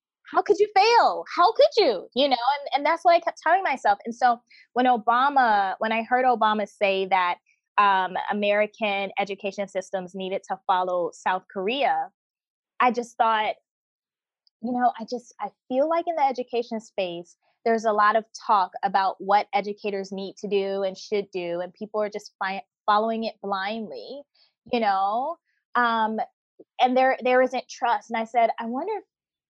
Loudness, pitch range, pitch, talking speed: -24 LUFS, 200-260 Hz, 225 Hz, 175 wpm